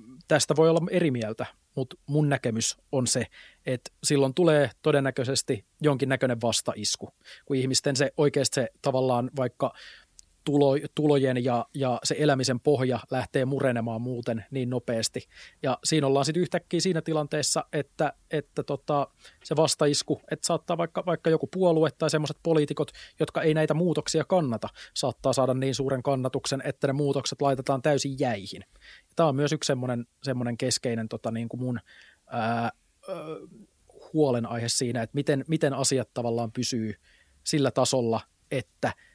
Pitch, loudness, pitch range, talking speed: 135 Hz, -27 LUFS, 125-150 Hz, 145 wpm